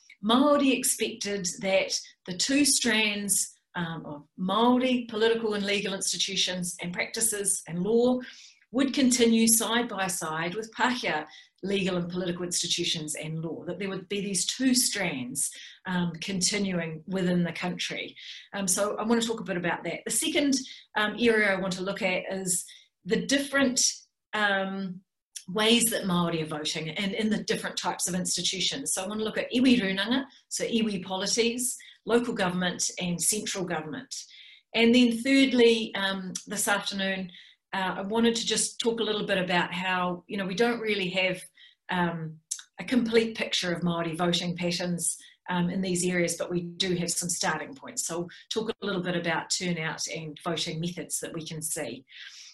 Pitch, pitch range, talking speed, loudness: 195 Hz, 175-225 Hz, 170 wpm, -27 LUFS